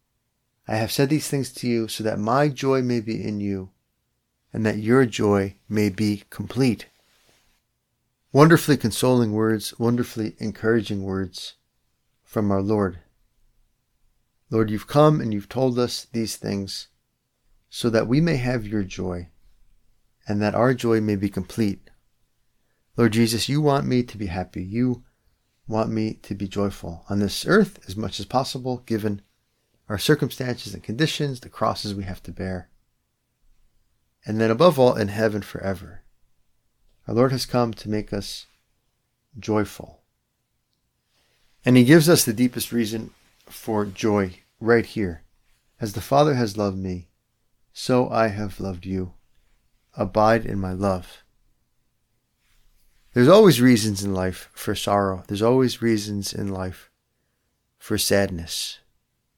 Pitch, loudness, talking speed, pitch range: 110 Hz, -22 LUFS, 140 wpm, 100-125 Hz